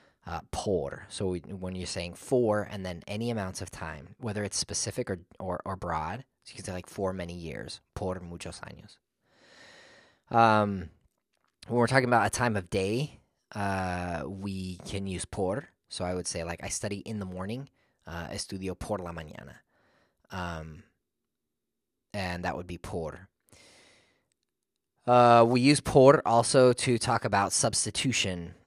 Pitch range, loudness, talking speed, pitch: 90-115 Hz, -28 LUFS, 160 wpm, 100 Hz